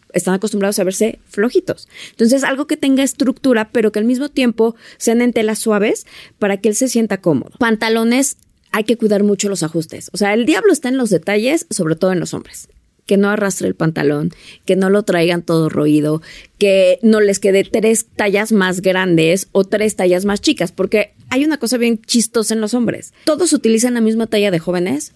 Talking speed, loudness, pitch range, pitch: 205 wpm, -15 LUFS, 190-240 Hz, 215 Hz